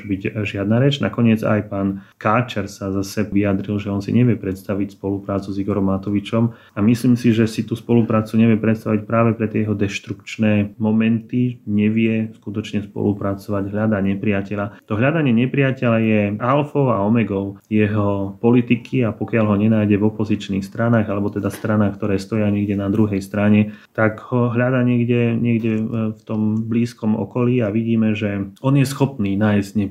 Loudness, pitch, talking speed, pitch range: -19 LUFS, 110 Hz, 165 wpm, 100-115 Hz